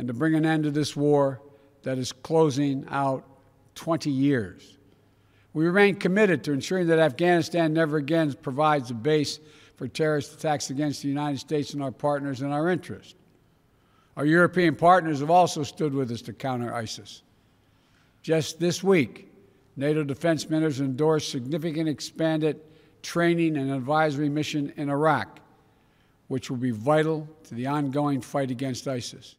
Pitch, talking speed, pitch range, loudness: 145 Hz, 155 wpm, 135-160 Hz, -25 LUFS